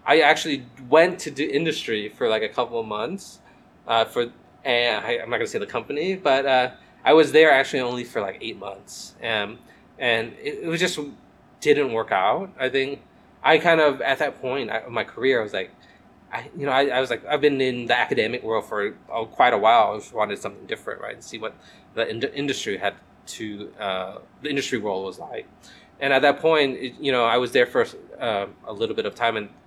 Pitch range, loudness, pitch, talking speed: 125-165 Hz, -22 LUFS, 145 Hz, 225 wpm